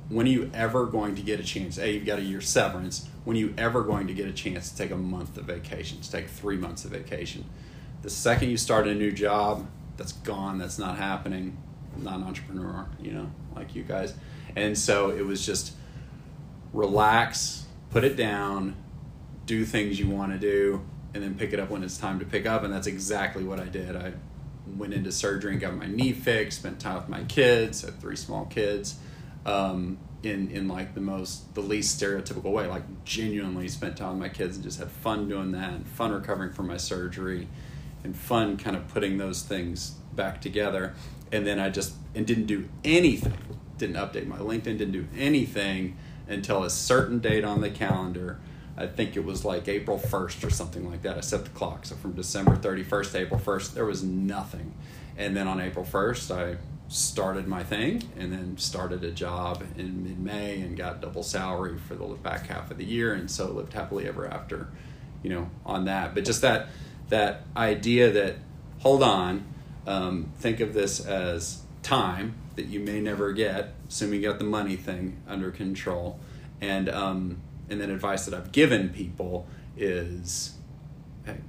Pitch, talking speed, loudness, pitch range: 100 Hz, 200 wpm, -29 LUFS, 95-105 Hz